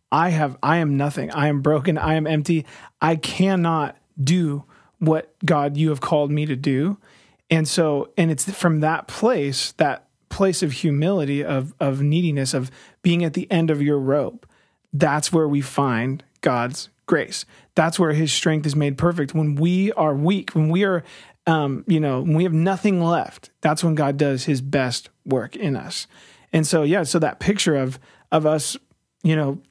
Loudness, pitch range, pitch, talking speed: -21 LUFS, 145-170 Hz, 155 Hz, 185 wpm